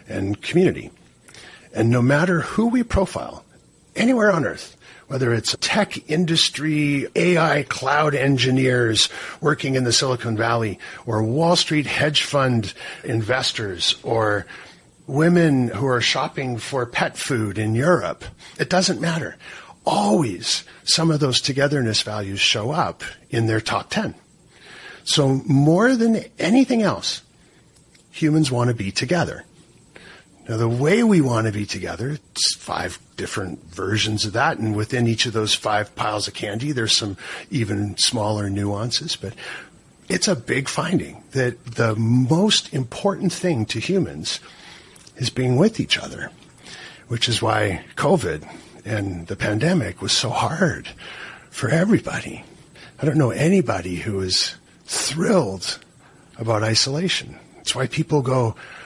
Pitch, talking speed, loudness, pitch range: 125 Hz, 135 wpm, -20 LUFS, 110-155 Hz